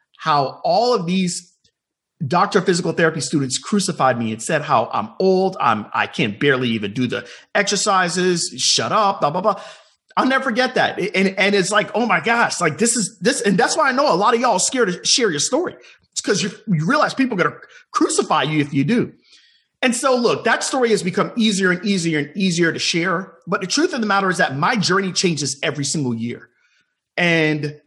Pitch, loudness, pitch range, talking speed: 185 Hz, -18 LUFS, 160-215 Hz, 215 wpm